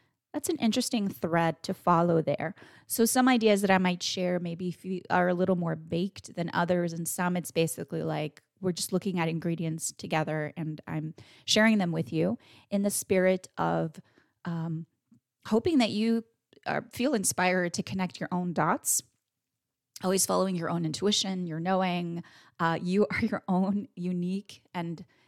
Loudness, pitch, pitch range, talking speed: -29 LUFS, 180 Hz, 165-195 Hz, 165 wpm